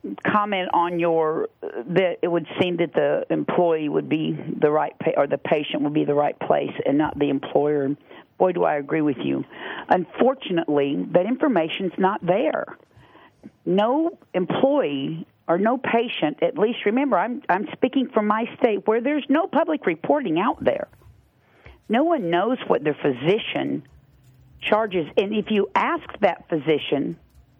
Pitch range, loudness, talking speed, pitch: 155-245 Hz, -22 LUFS, 160 wpm, 180 Hz